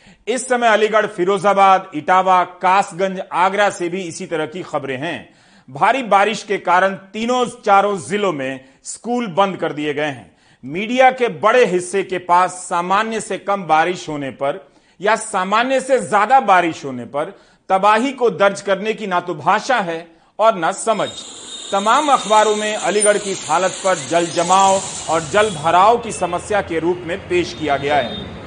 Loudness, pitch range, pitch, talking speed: -17 LUFS, 170-210 Hz, 190 Hz, 170 wpm